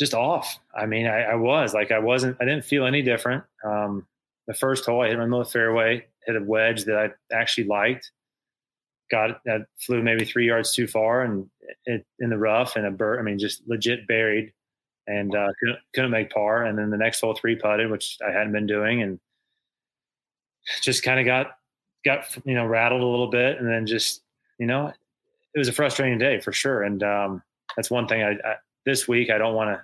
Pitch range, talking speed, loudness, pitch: 110-125 Hz, 215 wpm, -23 LUFS, 115 Hz